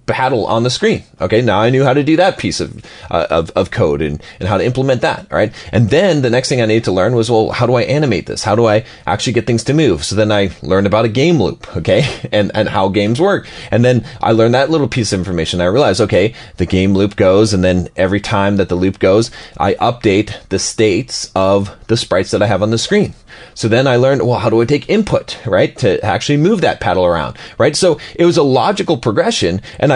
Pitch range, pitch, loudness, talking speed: 100-125 Hz, 110 Hz, -14 LUFS, 255 wpm